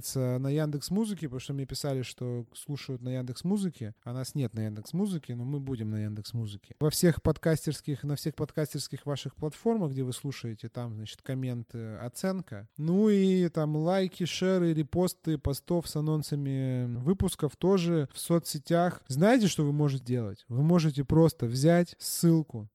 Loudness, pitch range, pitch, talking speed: -30 LUFS, 125-165 Hz, 145 Hz, 165 wpm